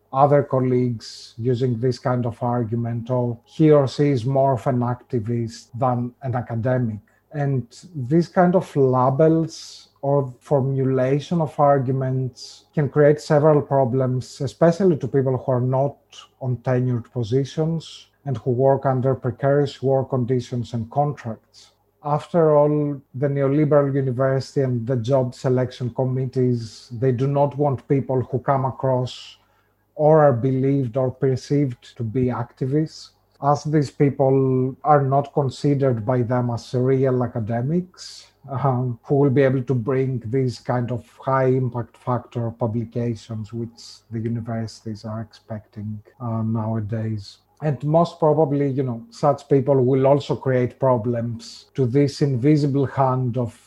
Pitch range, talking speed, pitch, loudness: 120-140 Hz, 140 wpm, 130 Hz, -21 LUFS